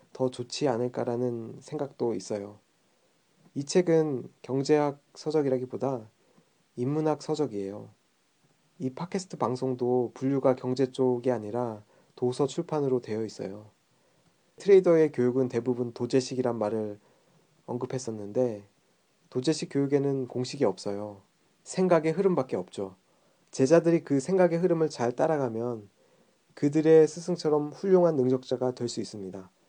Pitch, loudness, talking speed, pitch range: 130 Hz, -28 LUFS, 295 characters per minute, 120-155 Hz